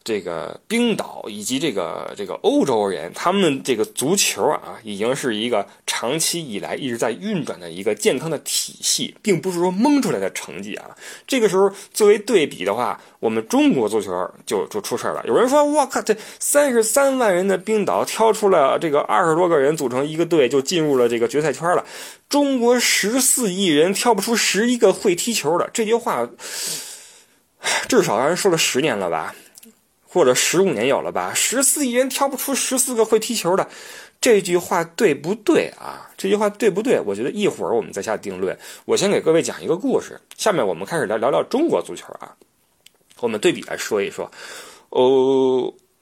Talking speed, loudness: 290 characters per minute, -19 LUFS